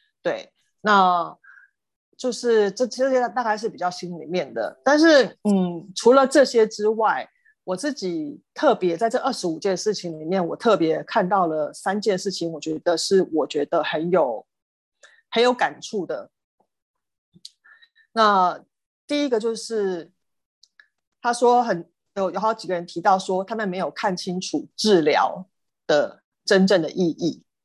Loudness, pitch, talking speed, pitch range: -22 LUFS, 205 Hz, 210 characters per minute, 180-245 Hz